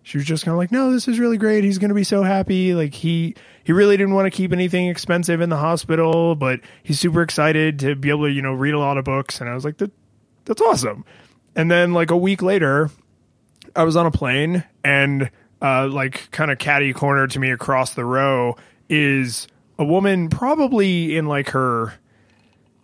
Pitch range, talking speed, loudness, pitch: 135-180 Hz, 215 wpm, -19 LUFS, 155 Hz